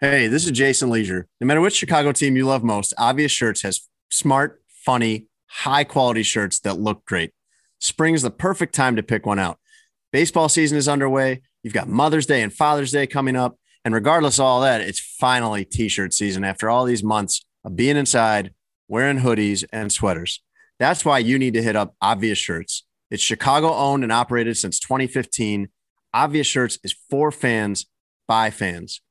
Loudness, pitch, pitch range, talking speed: -20 LUFS, 120 Hz, 105-140 Hz, 185 wpm